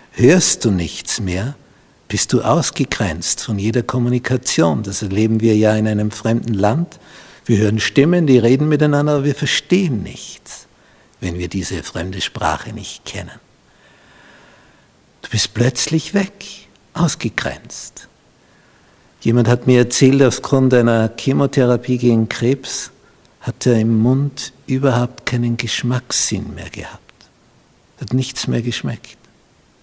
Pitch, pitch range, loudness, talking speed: 120 Hz, 110-135 Hz, -16 LUFS, 125 wpm